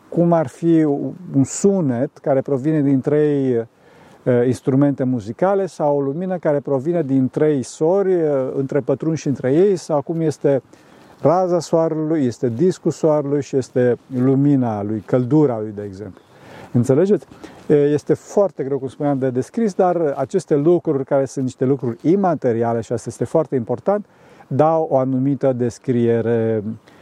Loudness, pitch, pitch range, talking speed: -19 LUFS, 140 Hz, 130-160 Hz, 145 wpm